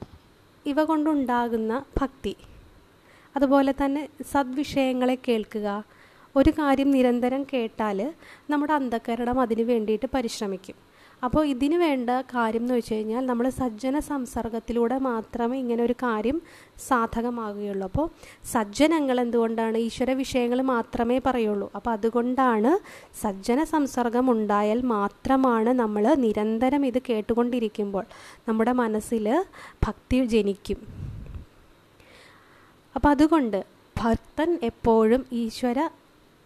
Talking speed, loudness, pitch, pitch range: 90 wpm, -25 LUFS, 245 Hz, 230-270 Hz